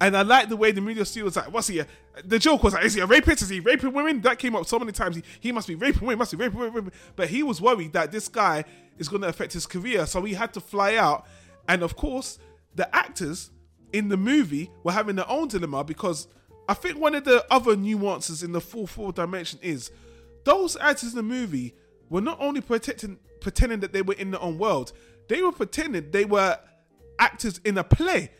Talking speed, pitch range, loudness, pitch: 240 wpm, 170-240 Hz, -24 LUFS, 200 Hz